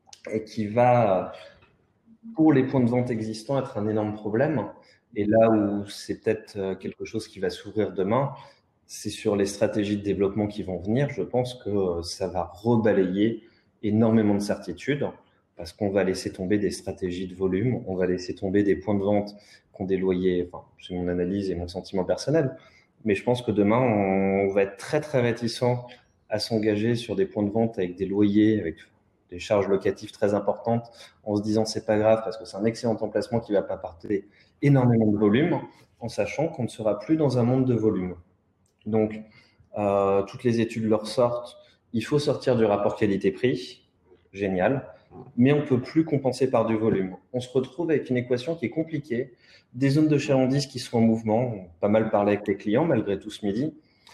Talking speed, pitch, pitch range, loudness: 200 wpm, 110 Hz, 100-120 Hz, -25 LUFS